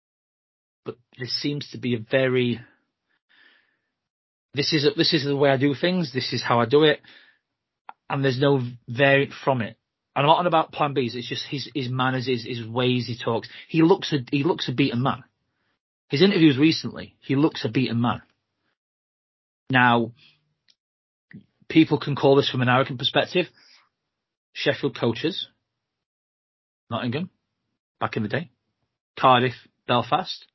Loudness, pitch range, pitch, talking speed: -23 LUFS, 120-145 Hz, 135 Hz, 155 wpm